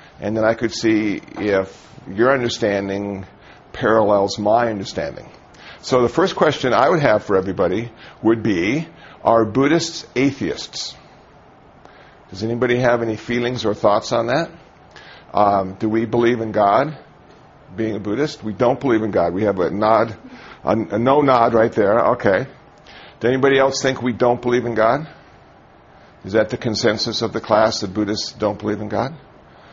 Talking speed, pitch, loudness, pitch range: 165 wpm, 115 Hz, -18 LUFS, 105-125 Hz